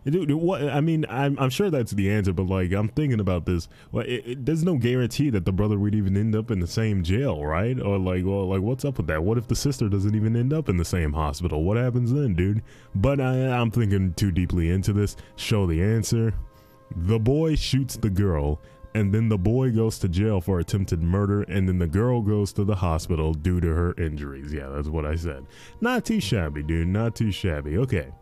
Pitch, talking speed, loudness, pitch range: 105 Hz, 230 wpm, -24 LUFS, 90-125 Hz